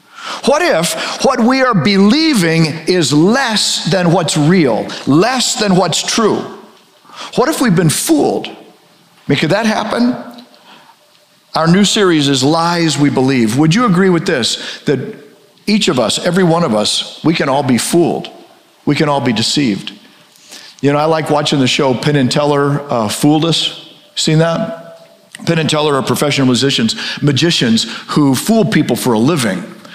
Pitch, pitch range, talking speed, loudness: 165 Hz, 145-205 Hz, 160 wpm, -12 LUFS